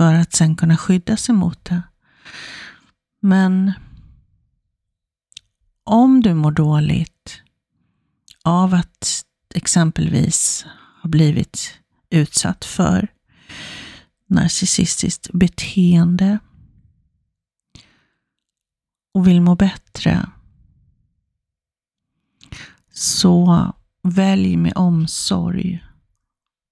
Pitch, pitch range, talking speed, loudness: 180 Hz, 165-190 Hz, 65 wpm, -17 LUFS